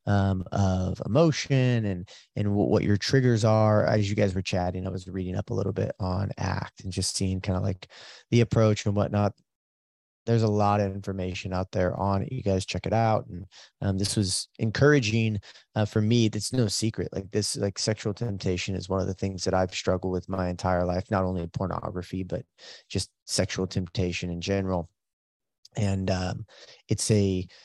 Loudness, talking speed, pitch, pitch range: -27 LUFS, 190 wpm, 95 Hz, 95-105 Hz